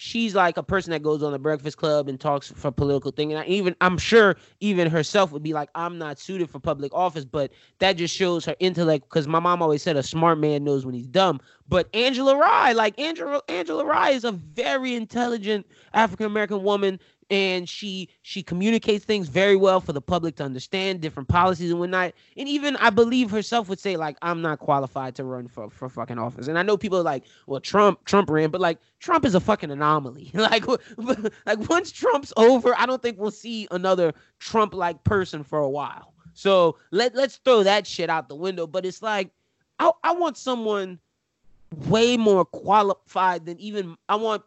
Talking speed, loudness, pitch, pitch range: 205 wpm, -23 LUFS, 185 Hz, 155-215 Hz